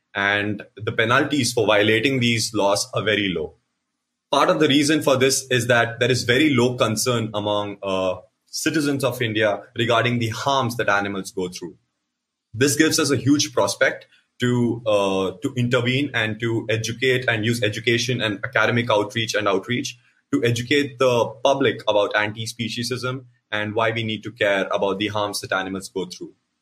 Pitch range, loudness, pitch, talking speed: 105-125 Hz, -21 LUFS, 115 Hz, 170 wpm